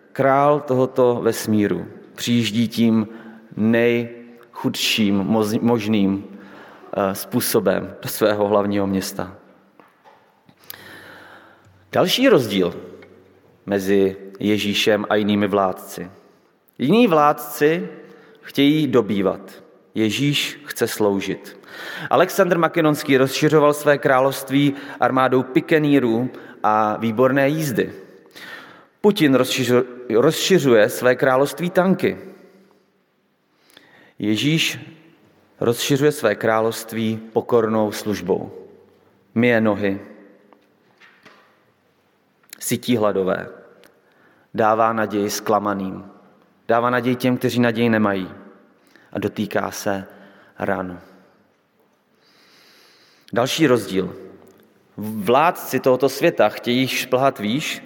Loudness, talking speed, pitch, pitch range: -19 LUFS, 75 wpm, 115 Hz, 105-135 Hz